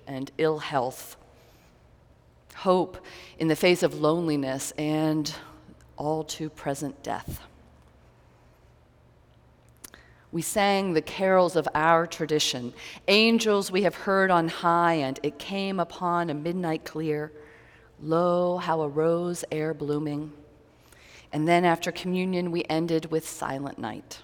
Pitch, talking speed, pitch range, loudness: 160 Hz, 120 wpm, 150-175 Hz, -26 LUFS